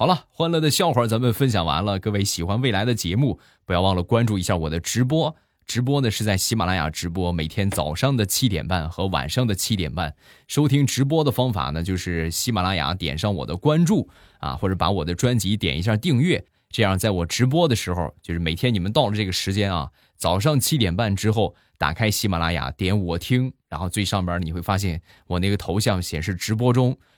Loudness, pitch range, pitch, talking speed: -22 LUFS, 90-120 Hz, 100 Hz, 330 characters per minute